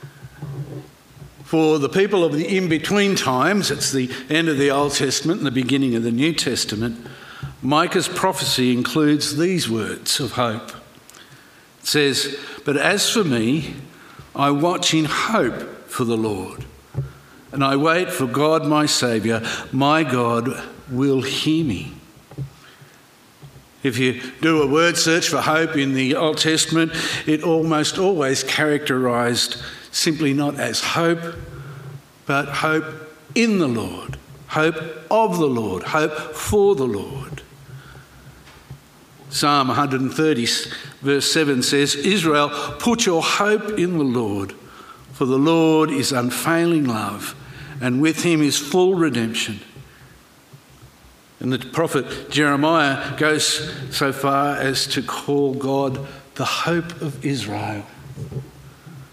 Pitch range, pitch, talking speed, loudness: 135-155 Hz, 140 Hz, 130 wpm, -19 LUFS